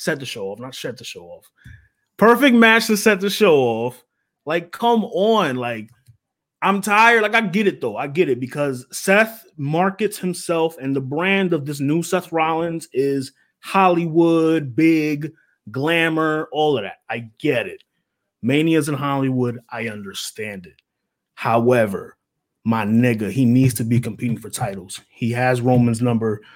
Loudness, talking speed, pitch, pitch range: -19 LUFS, 165 wpm, 150 Hz, 125-185 Hz